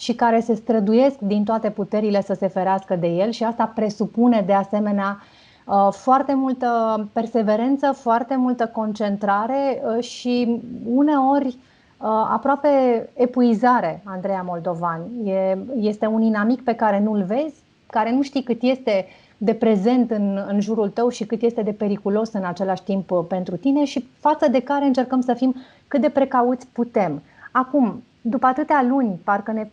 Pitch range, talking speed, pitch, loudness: 205-255 Hz, 145 wpm, 230 Hz, -21 LUFS